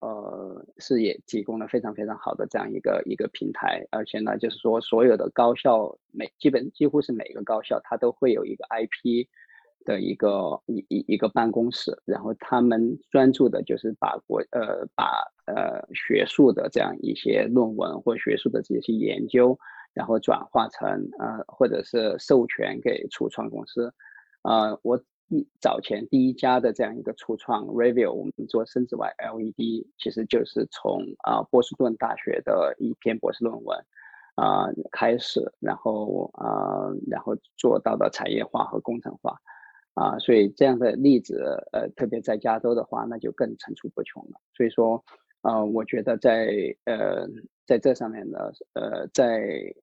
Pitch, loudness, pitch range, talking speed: 120 Hz, -25 LUFS, 115-135 Hz, 255 characters per minute